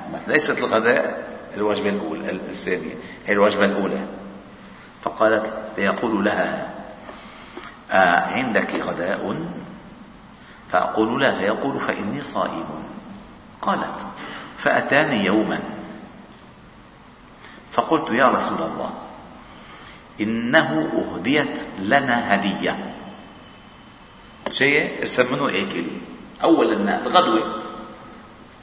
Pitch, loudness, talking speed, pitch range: 100 Hz, -21 LUFS, 75 wpm, 100-110 Hz